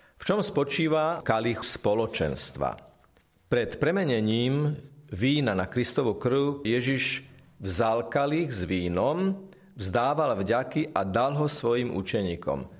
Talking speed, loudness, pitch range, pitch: 110 wpm, -27 LUFS, 115-150 Hz, 135 Hz